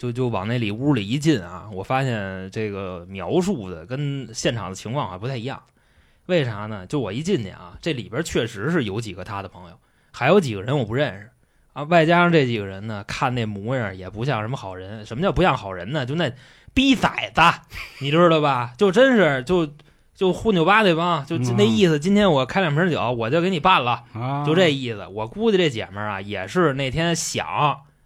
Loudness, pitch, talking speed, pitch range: -21 LUFS, 130 Hz, 300 characters per minute, 105-165 Hz